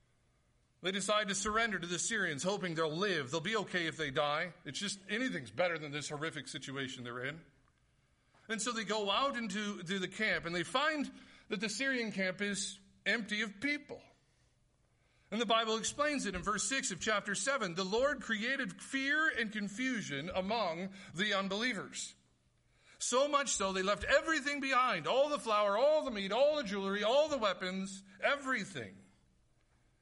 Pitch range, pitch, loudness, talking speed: 165-235 Hz, 200 Hz, -35 LUFS, 170 wpm